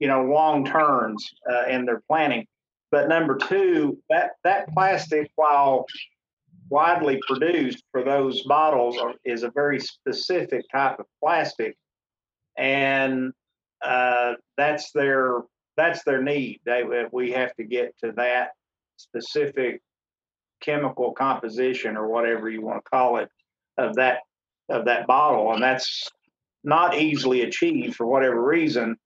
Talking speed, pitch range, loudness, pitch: 135 wpm, 125-155 Hz, -23 LUFS, 135 Hz